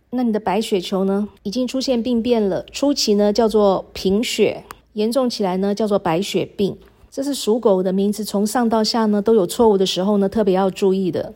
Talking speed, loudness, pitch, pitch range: 300 characters per minute, -19 LUFS, 210 Hz, 195-230 Hz